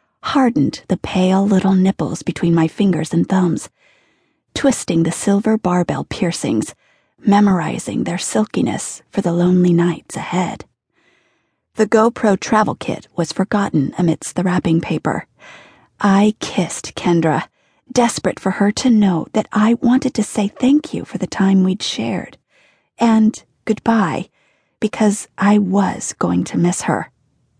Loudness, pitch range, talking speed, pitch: -17 LUFS, 175-215 Hz, 135 wpm, 195 Hz